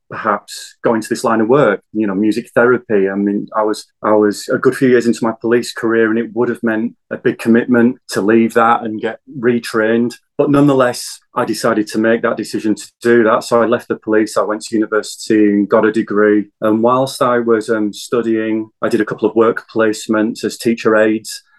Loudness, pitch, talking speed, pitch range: -15 LUFS, 115 Hz, 220 wpm, 110-120 Hz